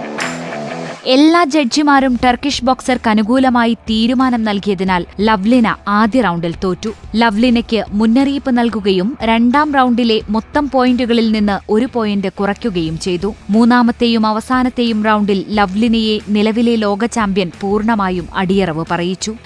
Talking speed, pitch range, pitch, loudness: 100 wpm, 205-245 Hz, 225 Hz, -14 LUFS